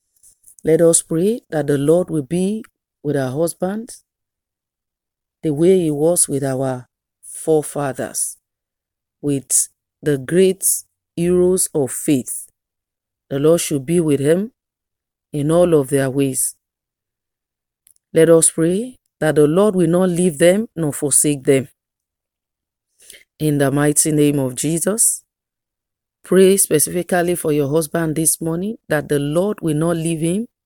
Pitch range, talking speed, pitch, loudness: 145-175 Hz, 135 wpm, 160 Hz, -17 LUFS